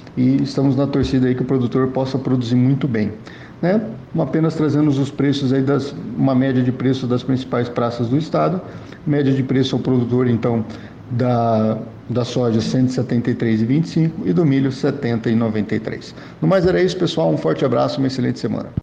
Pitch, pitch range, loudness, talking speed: 130 Hz, 120-140 Hz, -19 LUFS, 175 wpm